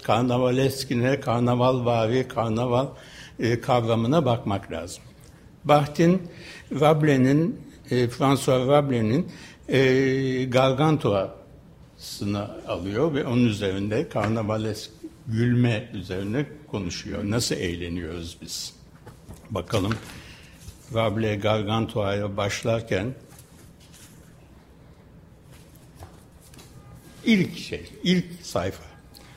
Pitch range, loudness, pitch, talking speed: 105-135 Hz, -24 LUFS, 120 Hz, 70 wpm